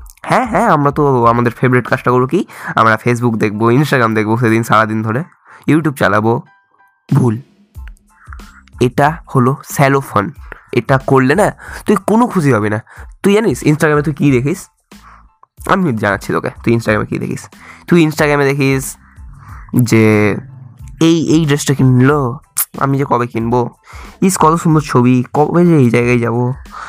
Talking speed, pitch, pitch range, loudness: 145 wpm, 130 Hz, 120-155 Hz, -13 LUFS